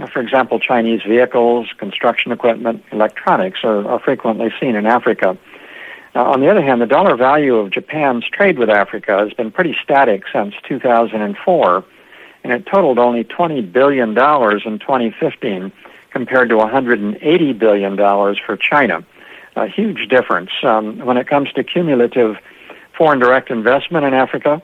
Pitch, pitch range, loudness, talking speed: 120 Hz, 110-130 Hz, -14 LUFS, 145 wpm